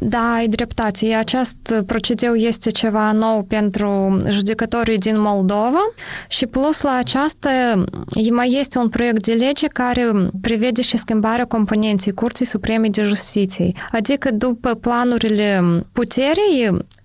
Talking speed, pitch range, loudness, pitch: 125 wpm, 215-245 Hz, -18 LUFS, 230 Hz